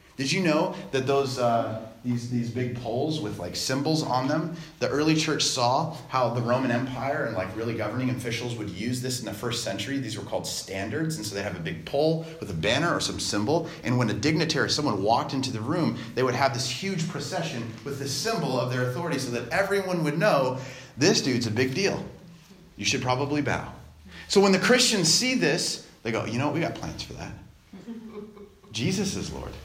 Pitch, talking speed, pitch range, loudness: 130 Hz, 215 wpm, 115-160 Hz, -26 LUFS